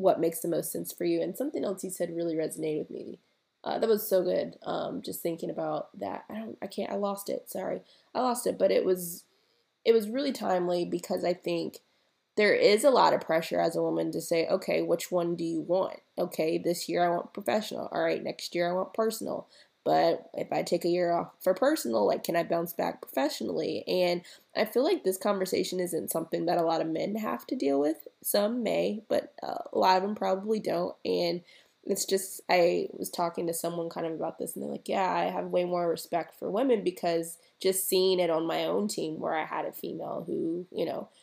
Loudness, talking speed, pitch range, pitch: -30 LUFS, 230 wpm, 170-200 Hz, 180 Hz